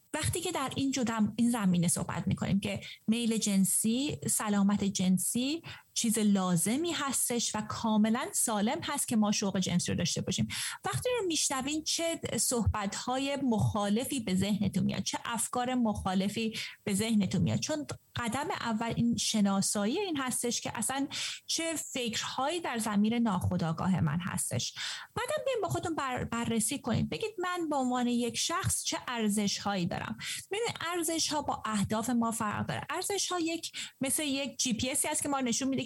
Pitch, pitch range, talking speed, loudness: 235 Hz, 205-280 Hz, 155 wpm, -31 LUFS